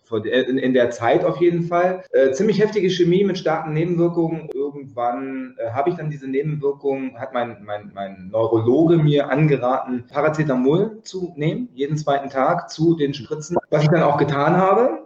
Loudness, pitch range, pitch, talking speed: -20 LUFS, 130-170 Hz, 145 Hz, 165 wpm